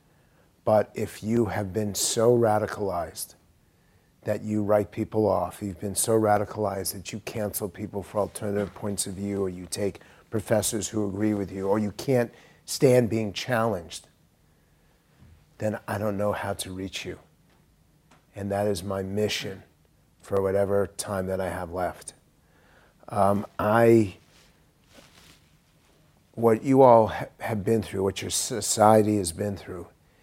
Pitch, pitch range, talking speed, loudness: 105 Hz, 95-110 Hz, 145 wpm, -26 LUFS